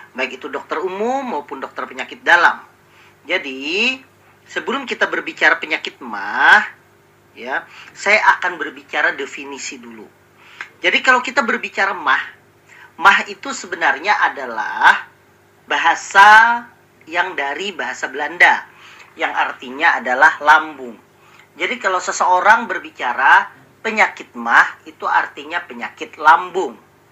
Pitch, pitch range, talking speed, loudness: 200 Hz, 180-250 Hz, 105 wpm, -15 LUFS